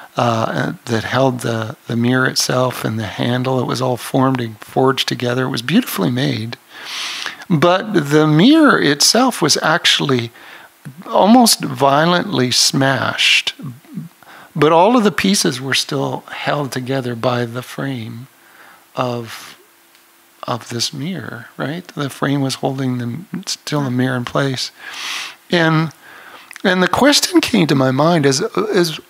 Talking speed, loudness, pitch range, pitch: 140 wpm, -16 LUFS, 125-165 Hz, 135 Hz